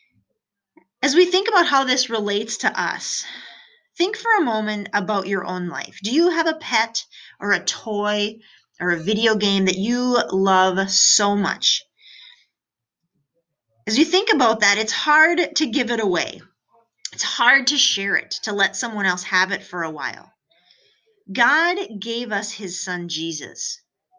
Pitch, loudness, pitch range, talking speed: 215 Hz, -19 LUFS, 195-310 Hz, 160 wpm